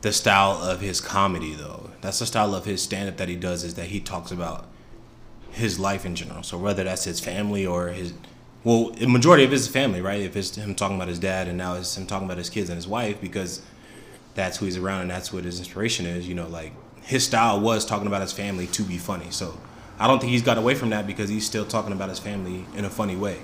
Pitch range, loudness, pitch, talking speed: 90-105 Hz, -24 LUFS, 100 Hz, 255 wpm